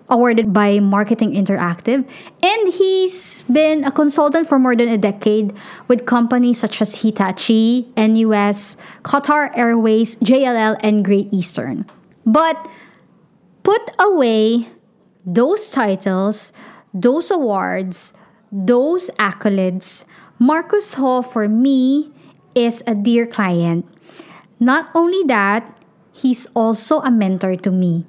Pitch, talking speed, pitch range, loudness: 230 Hz, 110 wpm, 205-265 Hz, -16 LUFS